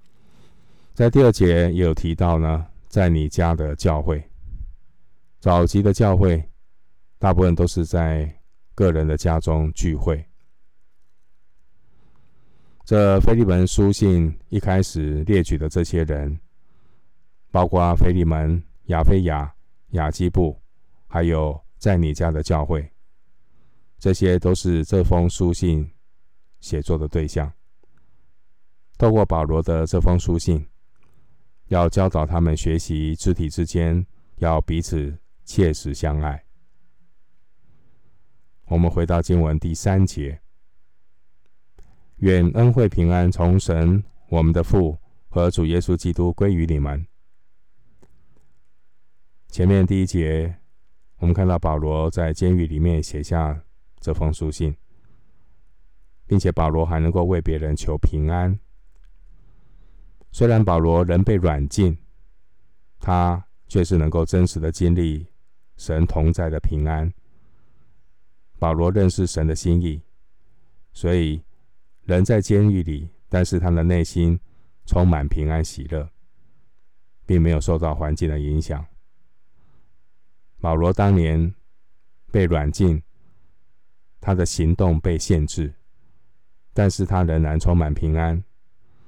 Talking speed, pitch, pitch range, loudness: 170 characters per minute, 85 Hz, 80-90 Hz, -21 LUFS